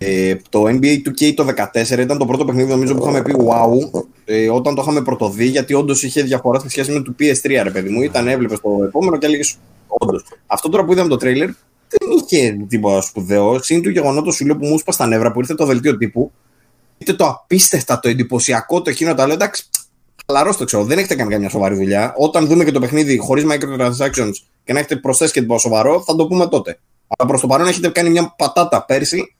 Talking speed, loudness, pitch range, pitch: 215 wpm, -15 LUFS, 120-150 Hz, 135 Hz